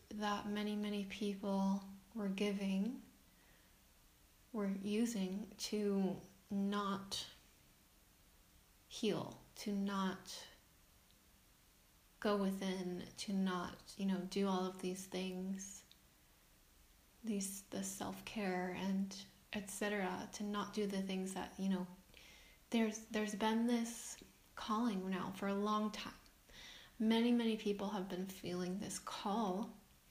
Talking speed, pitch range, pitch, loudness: 110 wpm, 190-210 Hz, 200 Hz, -41 LUFS